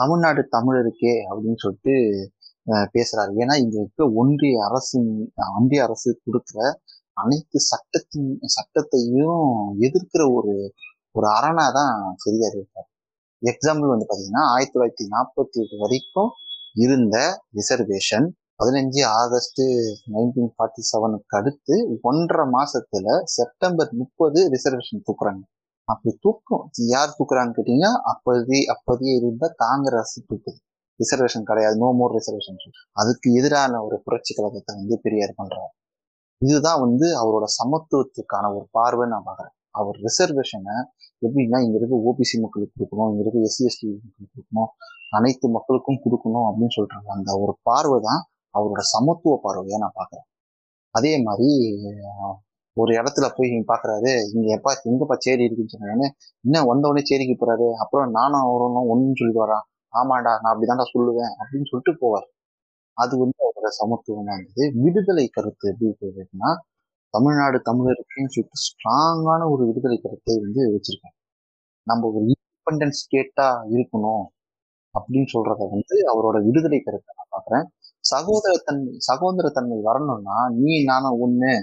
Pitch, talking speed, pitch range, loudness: 120 Hz, 125 wpm, 110-135 Hz, -21 LUFS